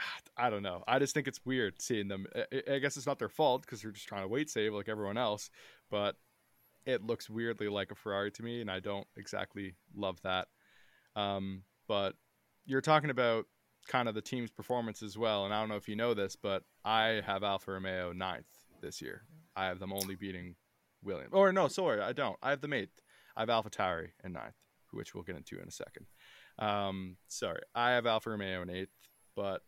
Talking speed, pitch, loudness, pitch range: 215 wpm, 105 Hz, -36 LUFS, 95-120 Hz